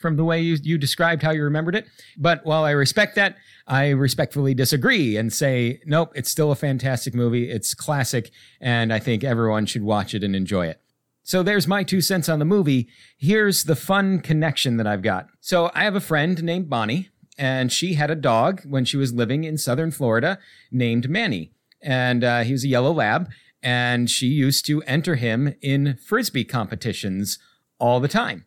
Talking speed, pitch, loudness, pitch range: 195 wpm, 140 Hz, -21 LUFS, 120-165 Hz